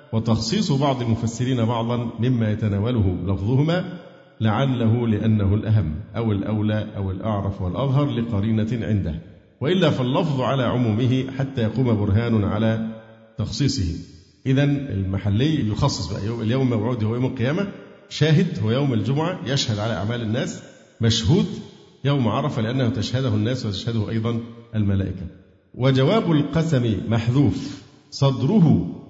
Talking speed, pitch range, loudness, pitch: 115 wpm, 105-135 Hz, -22 LUFS, 115 Hz